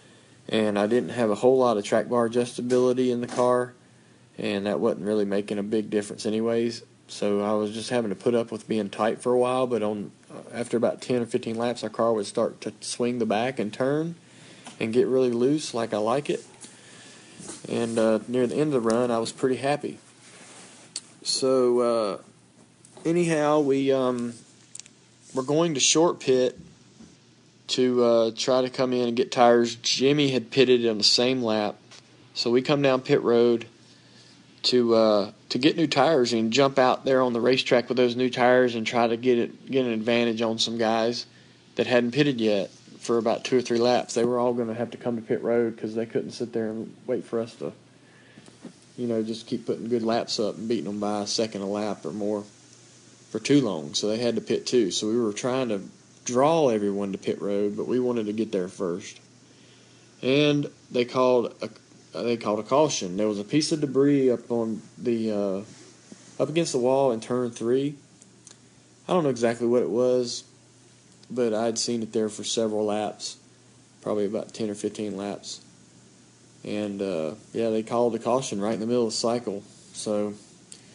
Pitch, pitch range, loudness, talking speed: 120 Hz, 110-125 Hz, -25 LUFS, 200 wpm